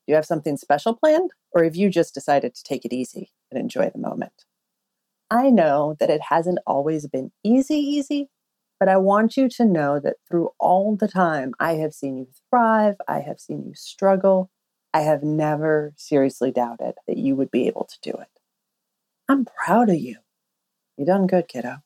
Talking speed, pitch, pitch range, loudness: 190 wpm, 190 Hz, 150-225 Hz, -21 LUFS